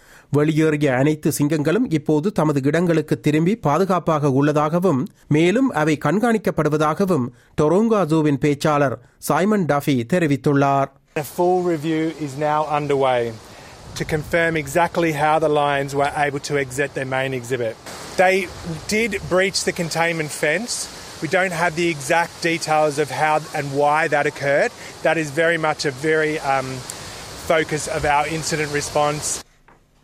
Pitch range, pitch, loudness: 145-170 Hz, 155 Hz, -20 LUFS